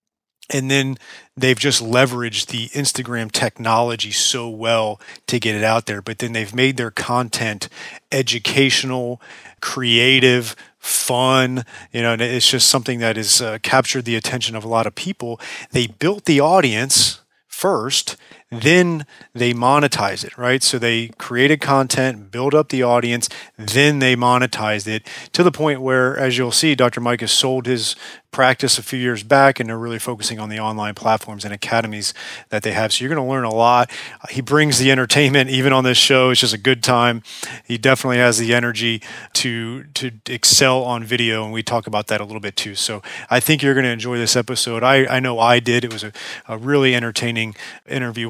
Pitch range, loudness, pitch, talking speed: 115-130 Hz, -17 LUFS, 125 Hz, 190 wpm